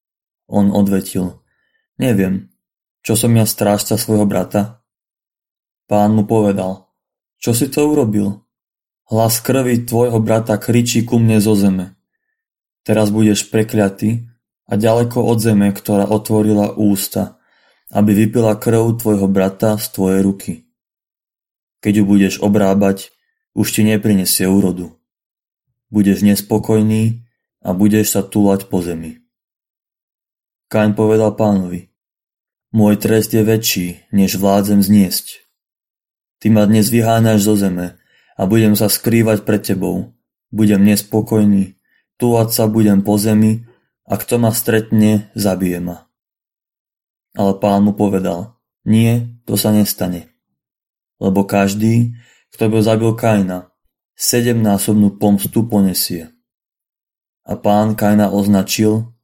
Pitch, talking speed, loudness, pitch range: 105 Hz, 120 wpm, -15 LUFS, 100-110 Hz